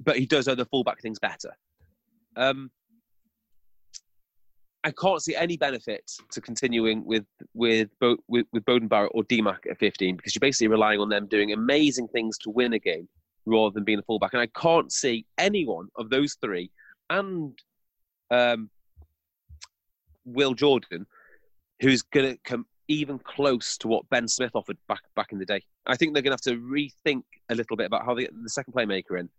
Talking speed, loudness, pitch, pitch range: 185 wpm, -26 LUFS, 120 Hz, 105-135 Hz